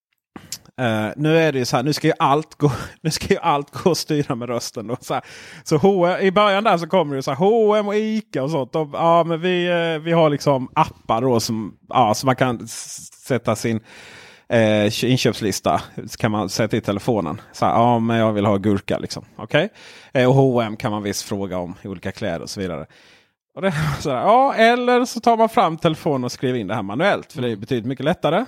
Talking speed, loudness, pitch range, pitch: 220 wpm, -19 LUFS, 115-170 Hz, 135 Hz